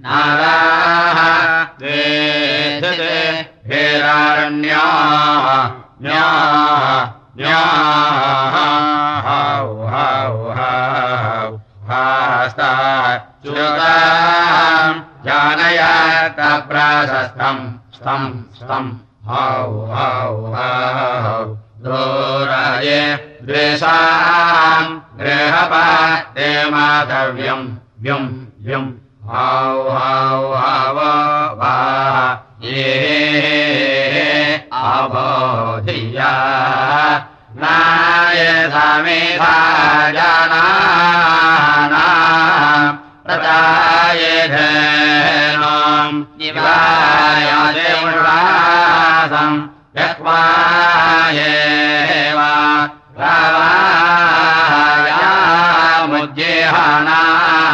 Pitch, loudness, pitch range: 150 Hz, -12 LUFS, 130-160 Hz